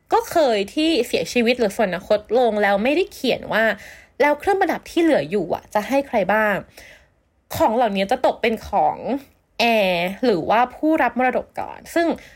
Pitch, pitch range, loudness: 245 Hz, 215-310 Hz, -20 LUFS